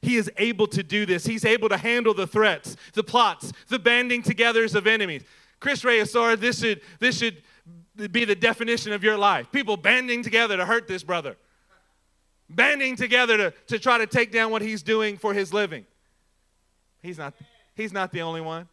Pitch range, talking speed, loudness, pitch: 185-235 Hz, 190 wpm, -22 LUFS, 215 Hz